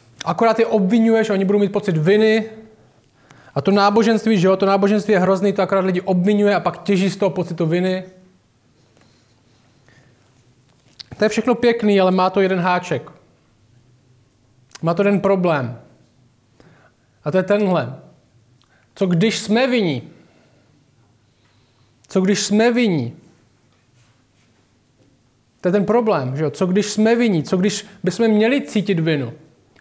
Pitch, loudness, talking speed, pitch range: 170 Hz, -18 LUFS, 140 wpm, 125-200 Hz